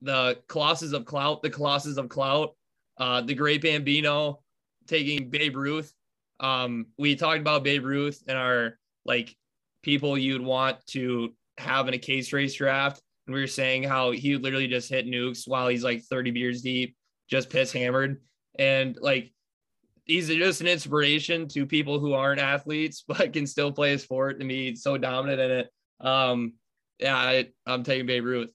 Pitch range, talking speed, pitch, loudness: 125-145 Hz, 175 wpm, 135 Hz, -26 LUFS